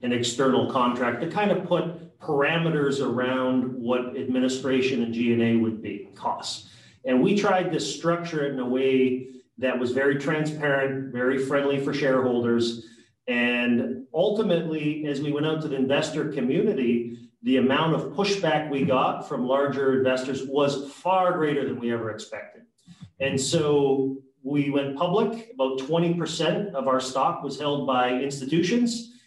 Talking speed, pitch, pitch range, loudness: 150 wpm, 135 Hz, 130-155 Hz, -25 LUFS